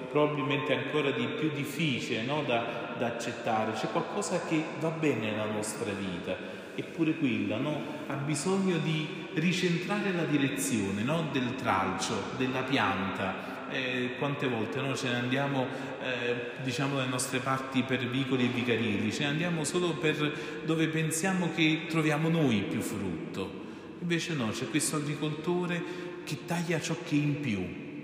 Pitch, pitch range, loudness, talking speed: 145 Hz, 125-160 Hz, -31 LUFS, 150 wpm